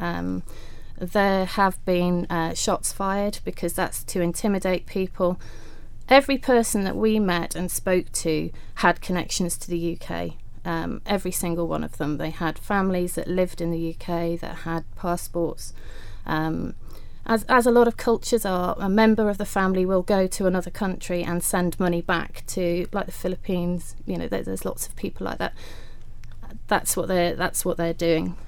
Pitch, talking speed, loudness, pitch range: 175 Hz, 175 wpm, -24 LUFS, 165-190 Hz